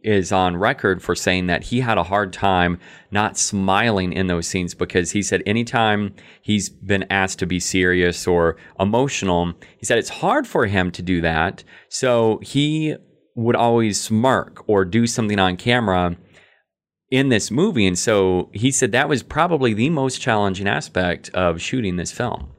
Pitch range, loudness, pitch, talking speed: 90-115 Hz, -19 LUFS, 95 Hz, 175 wpm